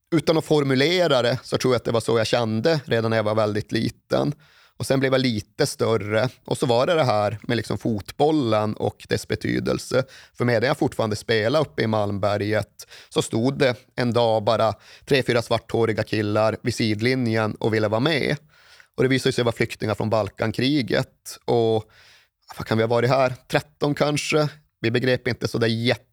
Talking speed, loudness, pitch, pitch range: 190 wpm, -22 LUFS, 115 Hz, 110-130 Hz